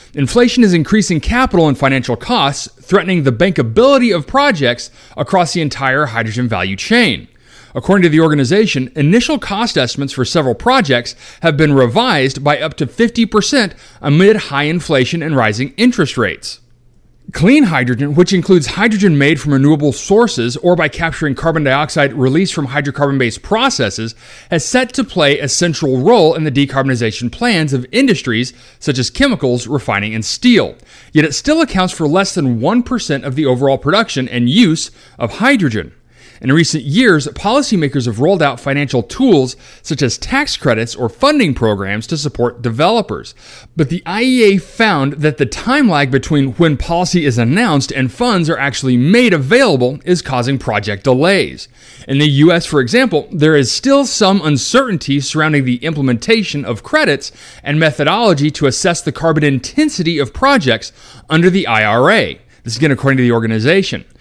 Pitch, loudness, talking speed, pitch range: 150 Hz, -13 LUFS, 160 wpm, 130-185 Hz